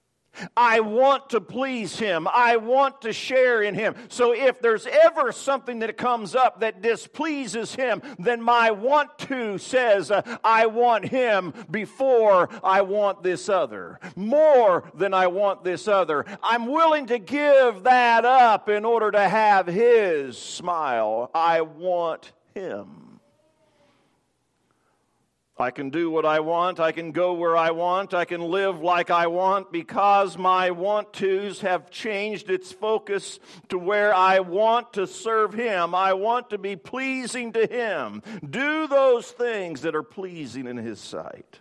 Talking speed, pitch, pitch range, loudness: 155 wpm, 210 Hz, 185-245 Hz, -22 LUFS